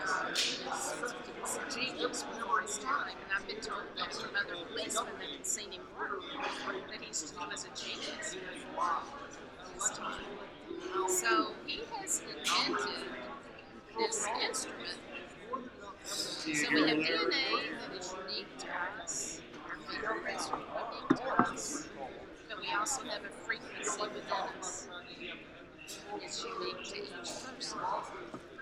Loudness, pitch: -36 LUFS, 325 Hz